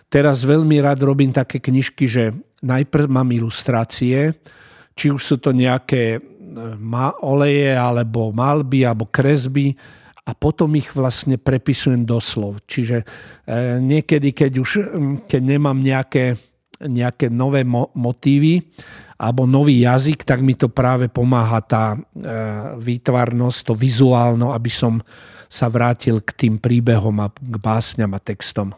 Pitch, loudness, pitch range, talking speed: 130 Hz, -17 LUFS, 120-140 Hz, 125 wpm